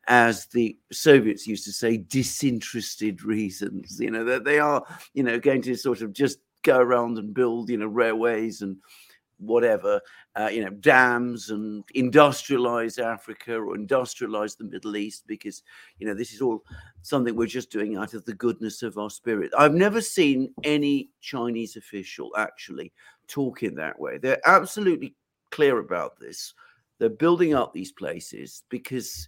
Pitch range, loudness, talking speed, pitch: 110-145 Hz, -24 LUFS, 165 wpm, 120 Hz